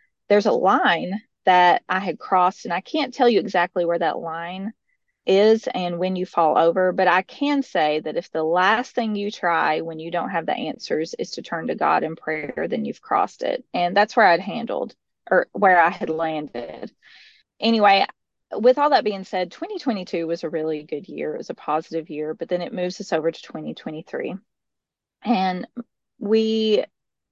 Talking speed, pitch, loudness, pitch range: 190 wpm, 185 Hz, -21 LUFS, 170-225 Hz